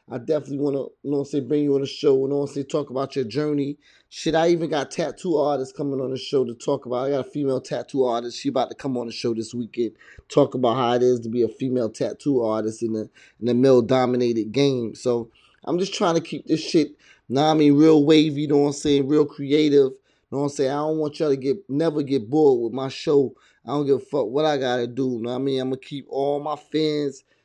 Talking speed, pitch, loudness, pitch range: 270 wpm, 140 Hz, -22 LUFS, 125-150 Hz